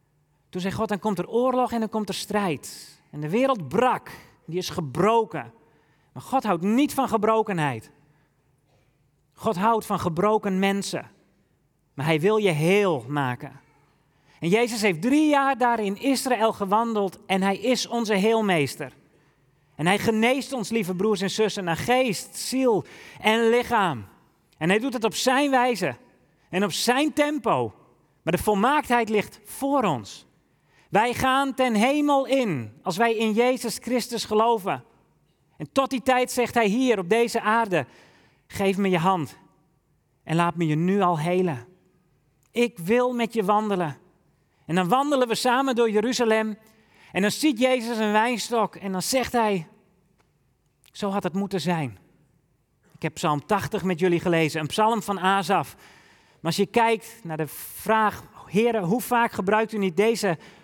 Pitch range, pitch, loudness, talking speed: 160-230 Hz, 200 Hz, -24 LUFS, 165 wpm